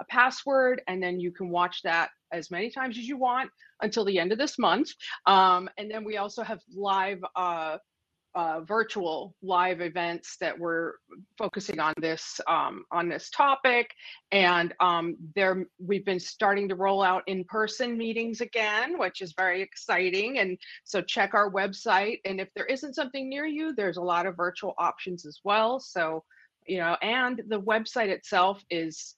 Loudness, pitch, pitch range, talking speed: -28 LUFS, 195 Hz, 180-225 Hz, 175 wpm